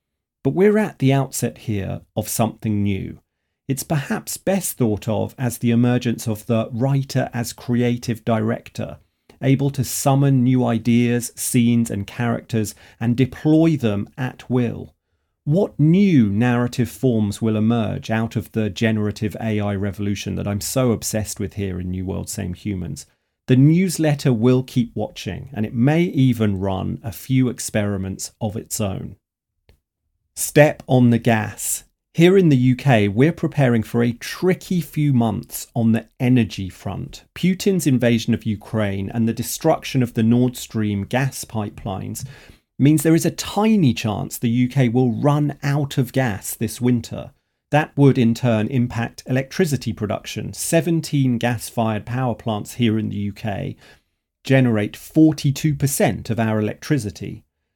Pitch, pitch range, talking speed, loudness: 120 Hz, 110-135 Hz, 150 wpm, -20 LUFS